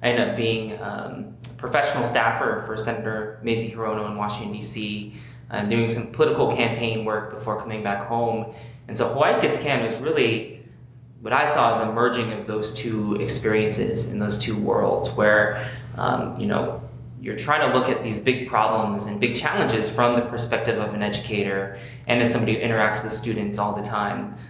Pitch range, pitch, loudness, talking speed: 105-120 Hz, 110 Hz, -23 LUFS, 190 wpm